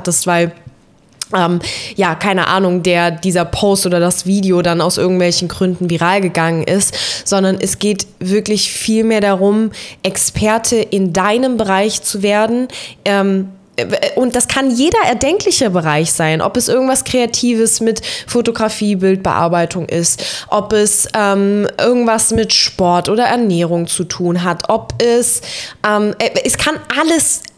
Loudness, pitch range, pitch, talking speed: -14 LUFS, 175-225 Hz, 200 Hz, 135 wpm